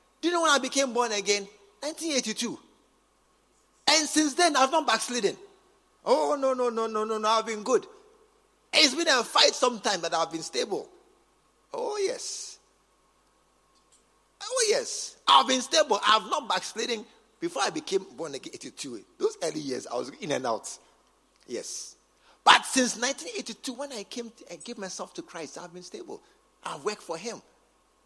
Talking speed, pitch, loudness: 165 wpm, 275 Hz, -26 LUFS